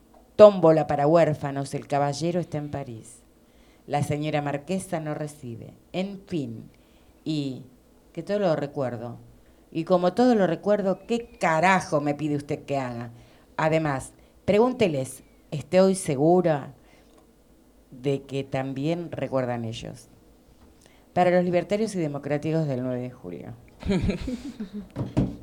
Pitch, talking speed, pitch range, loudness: 150 Hz, 120 wpm, 135-180 Hz, -25 LUFS